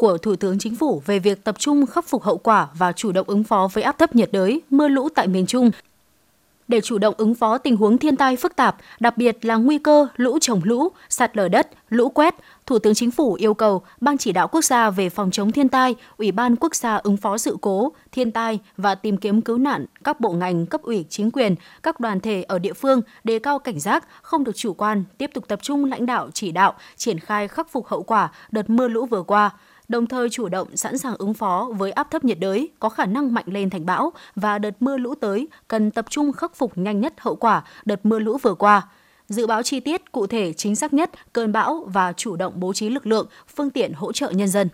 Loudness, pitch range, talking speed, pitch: -21 LUFS, 205-265 Hz, 250 wpm, 225 Hz